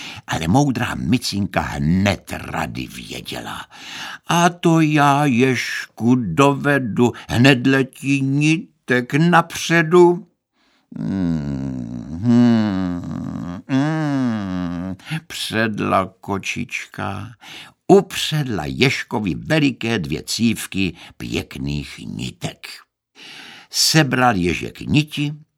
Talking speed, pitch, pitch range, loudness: 65 wpm, 125 Hz, 90-145 Hz, -19 LUFS